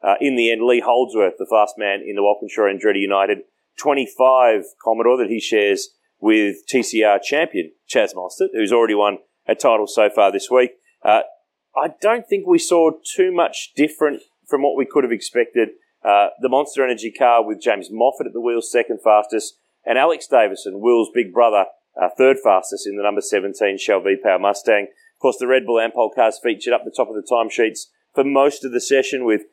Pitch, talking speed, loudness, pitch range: 130 Hz, 195 wpm, -18 LUFS, 110-170 Hz